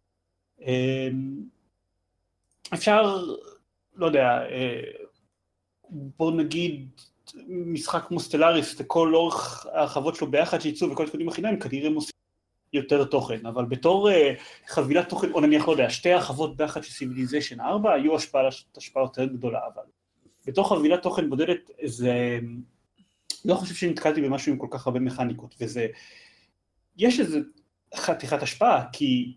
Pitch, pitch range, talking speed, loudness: 150 Hz, 125-175 Hz, 125 wpm, -25 LUFS